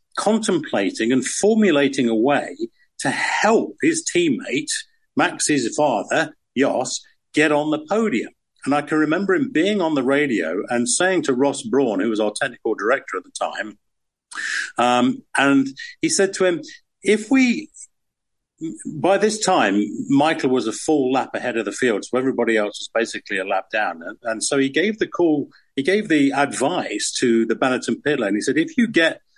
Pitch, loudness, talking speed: 185 Hz, -20 LUFS, 180 wpm